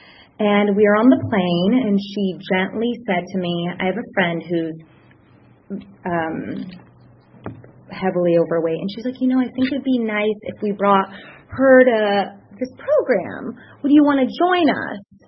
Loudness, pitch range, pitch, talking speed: -19 LUFS, 180-250 Hz, 205 Hz, 170 wpm